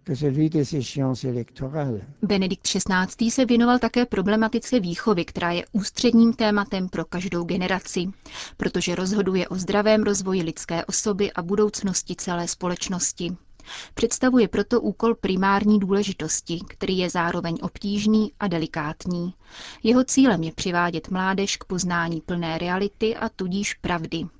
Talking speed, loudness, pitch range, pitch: 120 wpm, -23 LUFS, 170-210 Hz, 190 Hz